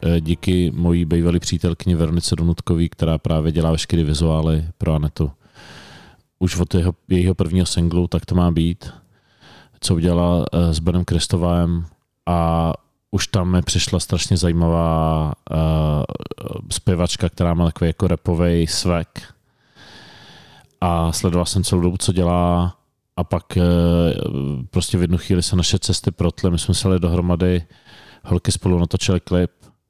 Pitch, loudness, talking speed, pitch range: 85 Hz, -19 LUFS, 135 wpm, 85-90 Hz